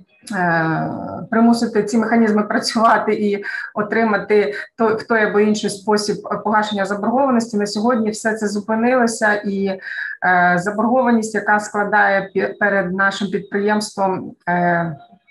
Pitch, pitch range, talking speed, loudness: 210 Hz, 200-220 Hz, 100 wpm, -18 LUFS